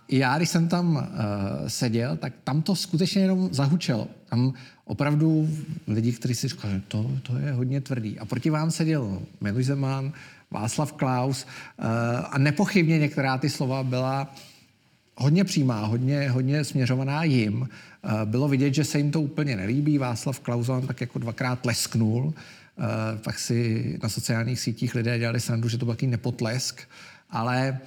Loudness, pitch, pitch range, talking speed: -26 LUFS, 130 Hz, 120-150 Hz, 160 wpm